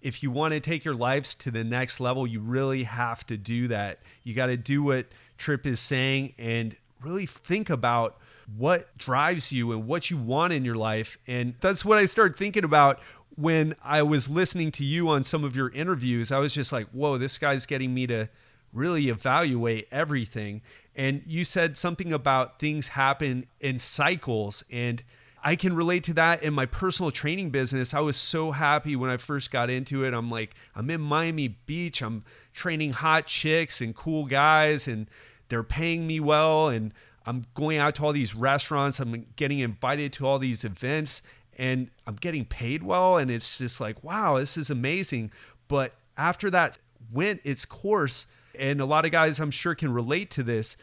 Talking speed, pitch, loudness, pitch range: 190 wpm, 135 Hz, -26 LUFS, 120-155 Hz